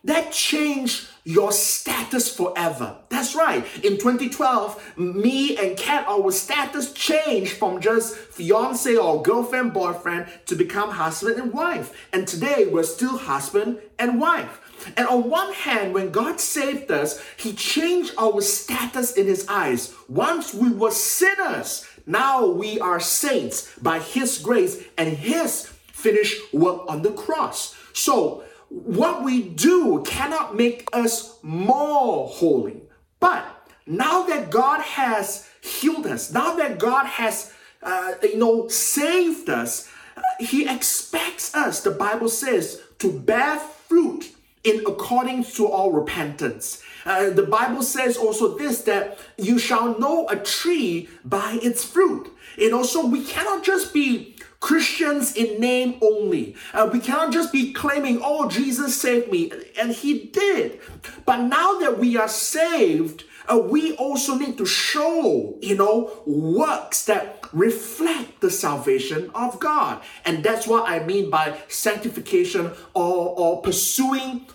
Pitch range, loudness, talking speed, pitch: 215-320 Hz, -22 LUFS, 140 wpm, 250 Hz